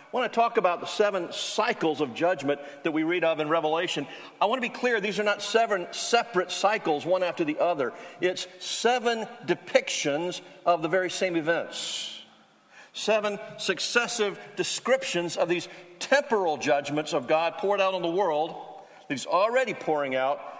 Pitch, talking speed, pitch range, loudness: 185 Hz, 165 wpm, 170-215 Hz, -27 LUFS